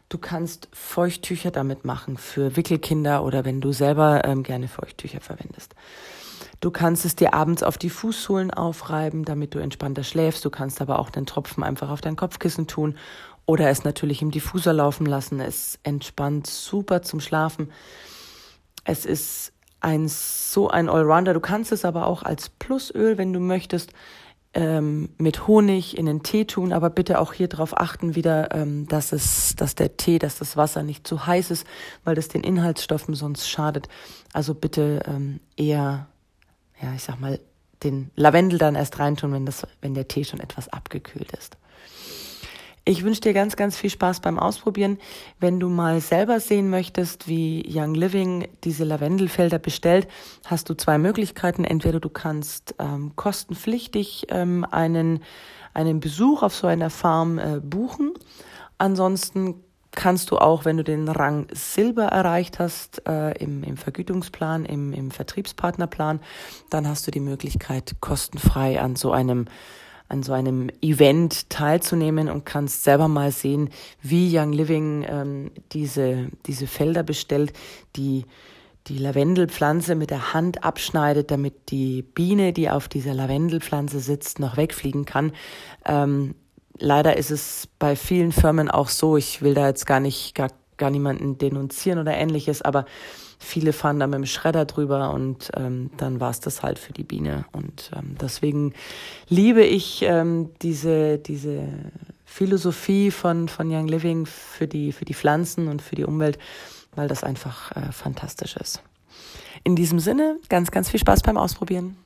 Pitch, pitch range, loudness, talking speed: 155 Hz, 145-175 Hz, -23 LUFS, 160 wpm